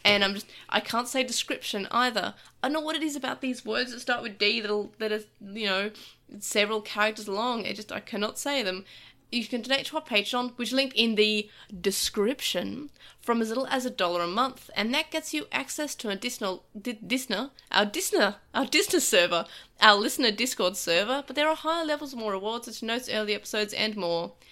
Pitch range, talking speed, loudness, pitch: 205-260 Hz, 210 wpm, -27 LUFS, 225 Hz